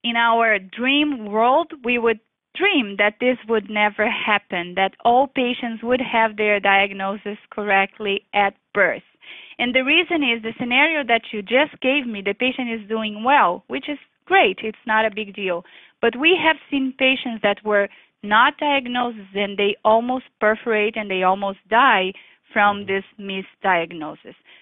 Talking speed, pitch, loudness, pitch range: 160 wpm, 225 Hz, -19 LUFS, 205-260 Hz